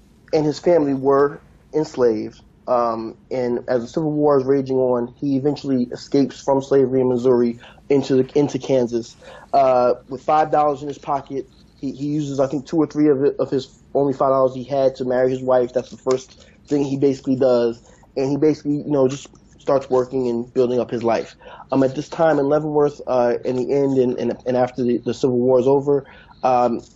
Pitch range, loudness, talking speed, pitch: 125-140 Hz, -20 LUFS, 210 wpm, 135 Hz